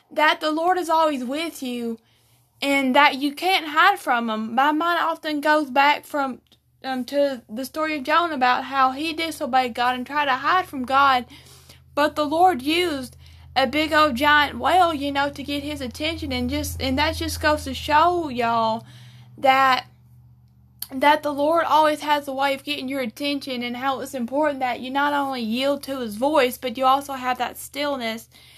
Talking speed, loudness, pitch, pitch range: 190 wpm, -21 LUFS, 280 Hz, 255-305 Hz